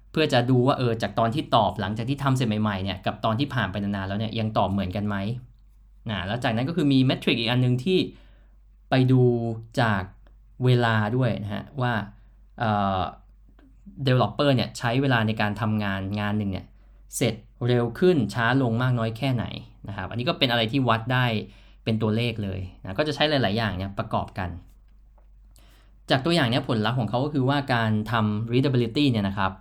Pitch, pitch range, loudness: 115 Hz, 105-125 Hz, -24 LUFS